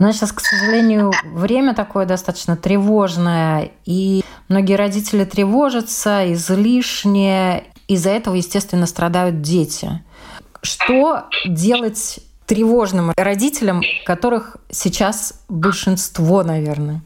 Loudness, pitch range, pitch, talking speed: -17 LUFS, 180-215 Hz, 195 Hz, 90 wpm